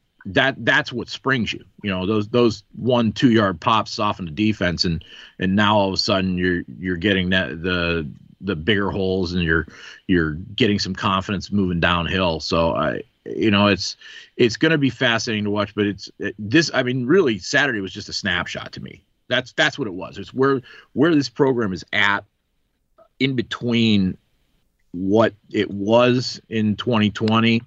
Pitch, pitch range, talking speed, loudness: 105 Hz, 95-115 Hz, 180 wpm, -20 LUFS